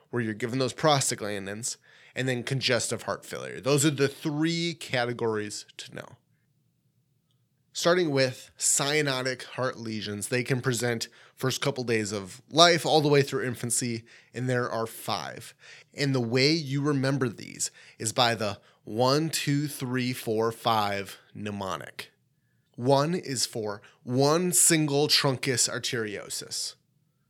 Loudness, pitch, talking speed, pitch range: -27 LUFS, 130 Hz, 135 wpm, 120-145 Hz